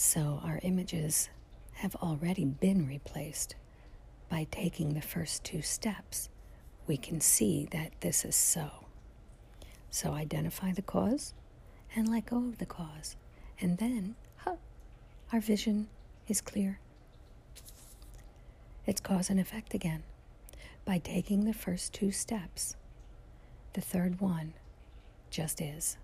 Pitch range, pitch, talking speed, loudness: 155-200 Hz, 180 Hz, 120 wpm, -34 LUFS